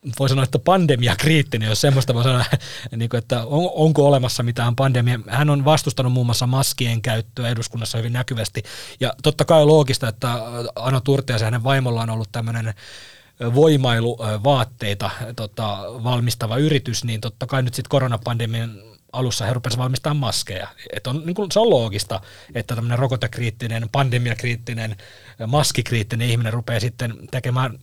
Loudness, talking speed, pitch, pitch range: -20 LUFS, 145 wpm, 120 Hz, 115-135 Hz